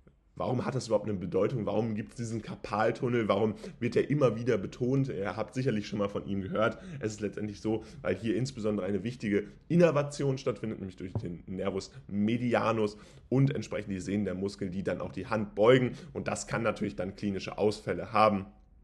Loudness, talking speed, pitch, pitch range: -31 LUFS, 195 wpm, 110 Hz, 100-120 Hz